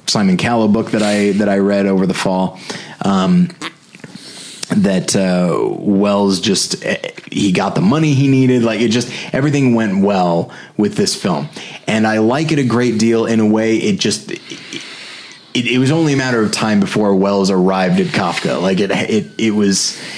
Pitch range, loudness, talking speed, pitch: 100-125 Hz, -14 LUFS, 185 wpm, 110 Hz